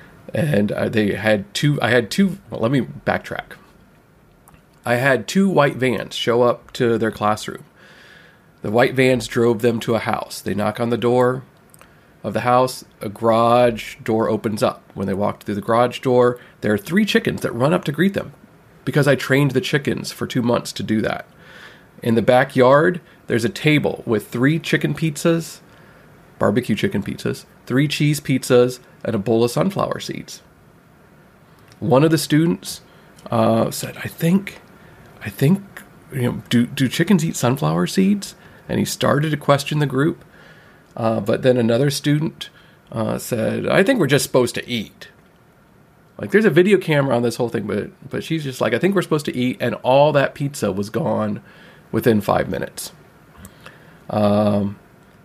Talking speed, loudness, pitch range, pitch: 175 wpm, -19 LUFS, 120-165 Hz, 130 Hz